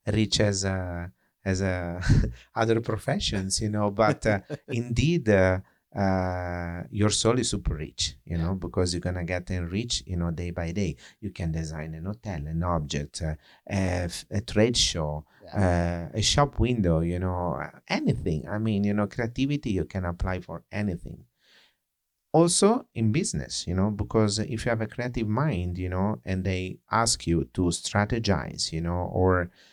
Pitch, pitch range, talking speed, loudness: 95 Hz, 85-110 Hz, 170 wpm, -27 LUFS